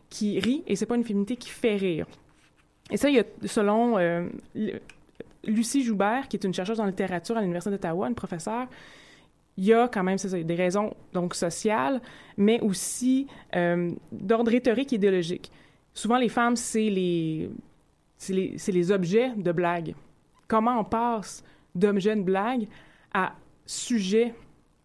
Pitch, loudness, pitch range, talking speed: 210 Hz, -26 LUFS, 185-235 Hz, 160 wpm